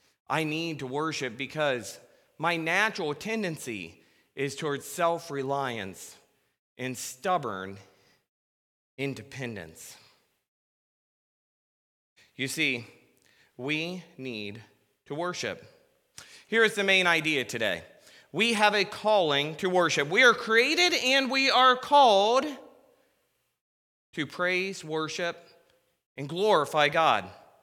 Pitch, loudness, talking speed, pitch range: 160 Hz, -26 LUFS, 100 wpm, 130-195 Hz